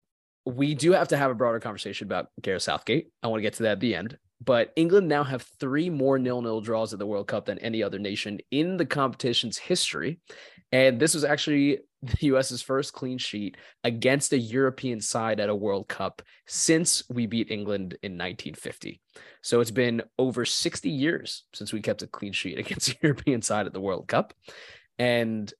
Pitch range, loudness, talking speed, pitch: 110-140 Hz, -26 LUFS, 200 wpm, 125 Hz